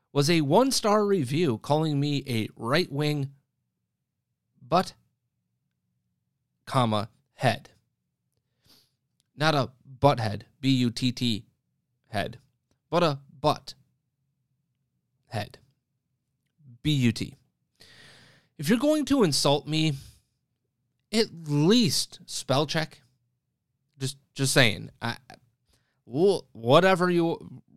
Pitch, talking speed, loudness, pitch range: 135 Hz, 90 wpm, -26 LUFS, 125-150 Hz